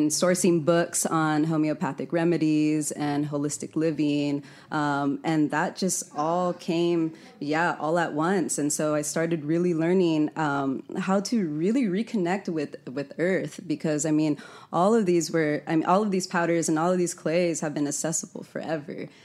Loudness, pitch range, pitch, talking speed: -26 LUFS, 150-175 Hz, 160 Hz, 170 wpm